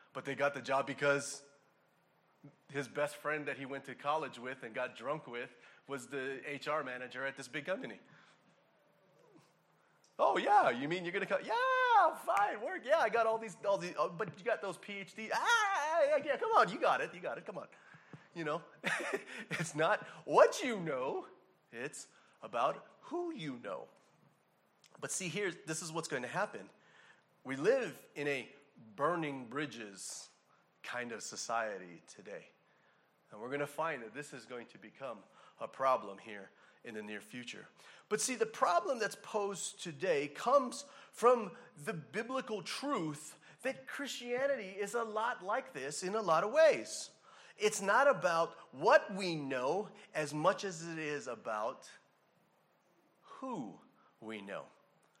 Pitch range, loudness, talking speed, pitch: 140-230 Hz, -36 LUFS, 160 wpm, 175 Hz